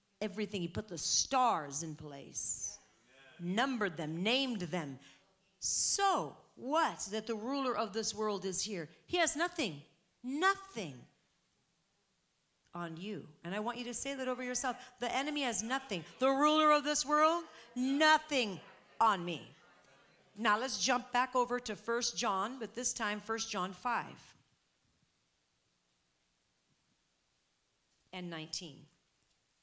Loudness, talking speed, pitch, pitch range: -34 LUFS, 130 wpm, 220 Hz, 170-255 Hz